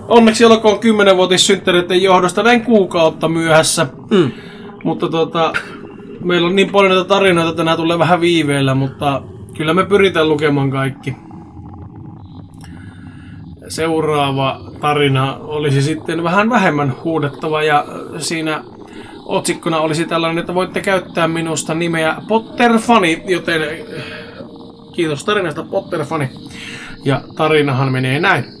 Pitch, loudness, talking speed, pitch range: 160 Hz, -14 LUFS, 115 wpm, 140-185 Hz